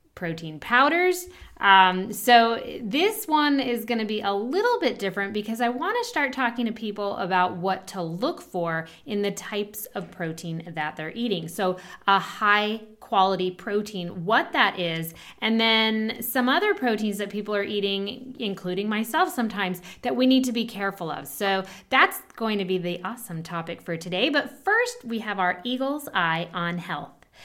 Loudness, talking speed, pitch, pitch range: -24 LUFS, 175 wpm, 205 Hz, 185-240 Hz